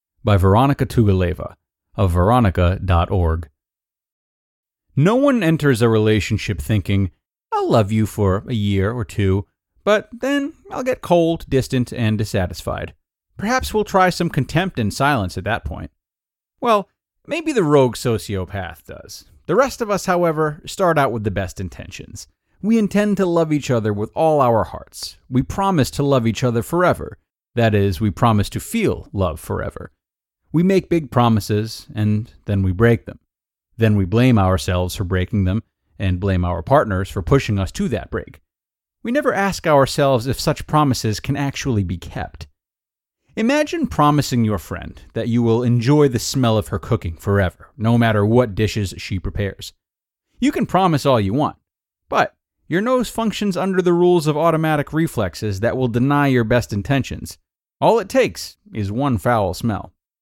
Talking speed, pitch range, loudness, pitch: 165 wpm, 100-150 Hz, -19 LUFS, 115 Hz